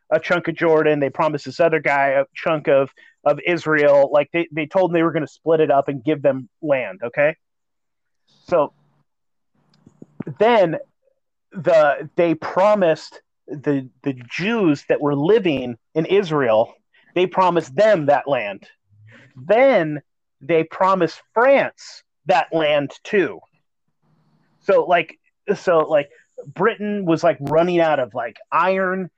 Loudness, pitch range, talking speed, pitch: -19 LUFS, 145-180 Hz, 140 wpm, 160 Hz